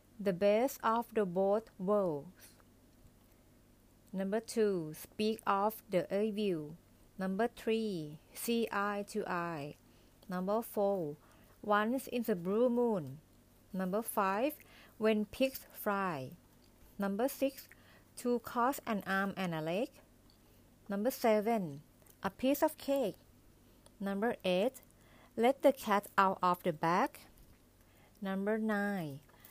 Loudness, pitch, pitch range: -35 LUFS, 200 Hz, 170-225 Hz